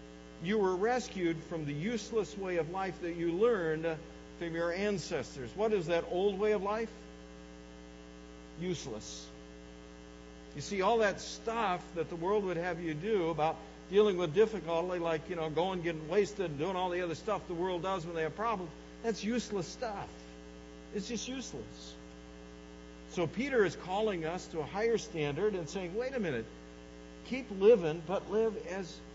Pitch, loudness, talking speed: 170 Hz, -34 LUFS, 175 wpm